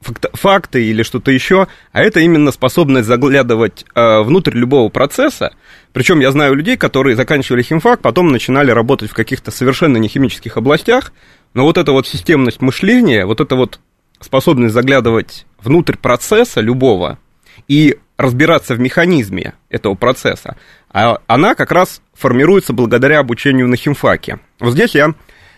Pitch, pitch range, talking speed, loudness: 135 Hz, 120-150 Hz, 135 wpm, -12 LUFS